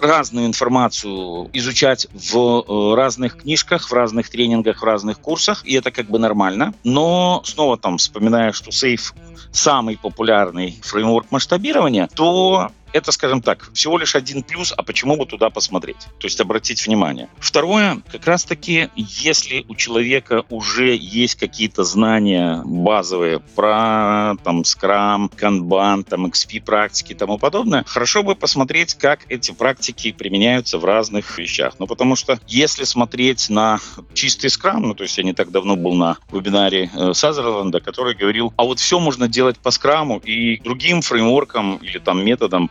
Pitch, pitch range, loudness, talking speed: 115 Hz, 105-130 Hz, -17 LUFS, 155 wpm